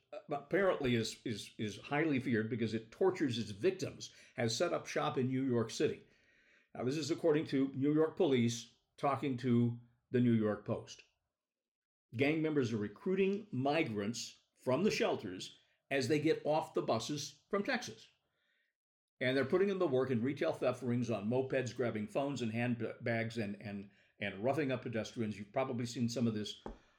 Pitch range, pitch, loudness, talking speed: 115-145 Hz, 125 Hz, -36 LUFS, 175 wpm